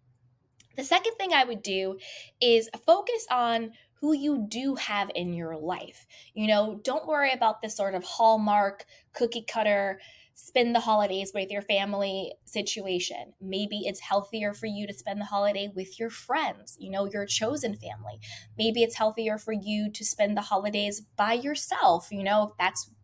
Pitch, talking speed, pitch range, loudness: 205 Hz, 170 wpm, 195-230 Hz, -27 LUFS